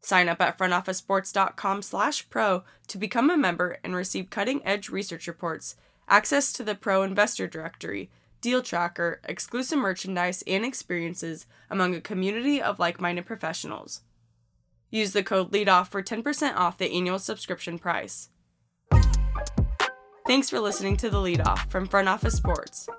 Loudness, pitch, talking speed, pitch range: -26 LUFS, 190 Hz, 140 wpm, 175-210 Hz